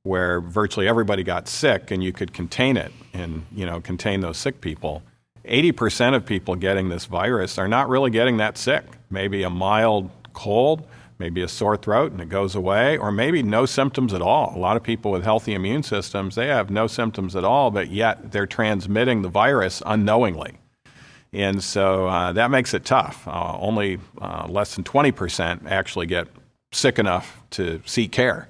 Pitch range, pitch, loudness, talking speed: 95-115 Hz, 100 Hz, -22 LUFS, 185 wpm